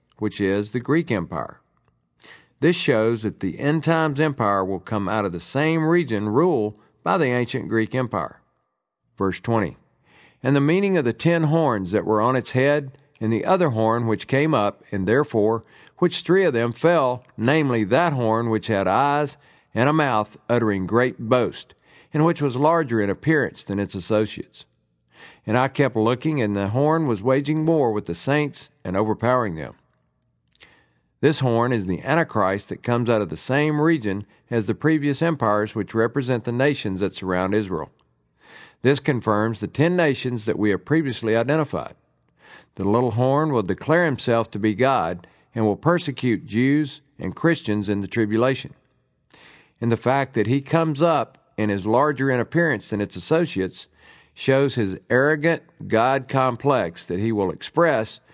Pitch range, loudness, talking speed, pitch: 105-145 Hz, -22 LUFS, 170 wpm, 120 Hz